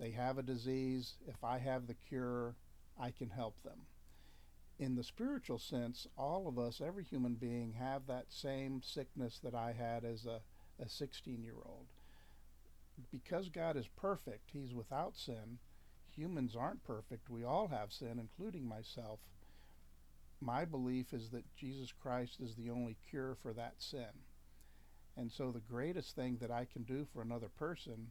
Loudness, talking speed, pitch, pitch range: -45 LUFS, 160 wpm, 120 Hz, 110-130 Hz